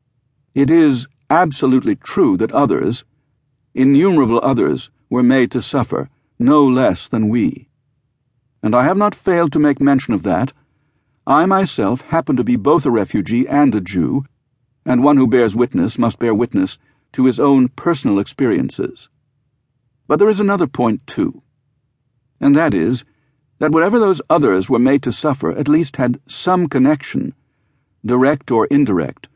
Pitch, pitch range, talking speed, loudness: 135 Hz, 125-145 Hz, 155 wpm, -15 LUFS